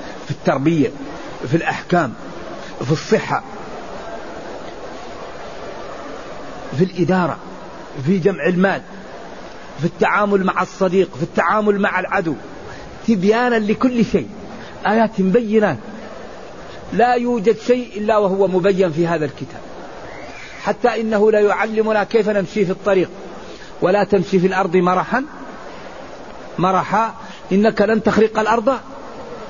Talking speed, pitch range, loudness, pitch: 105 wpm, 185-220 Hz, -17 LUFS, 200 Hz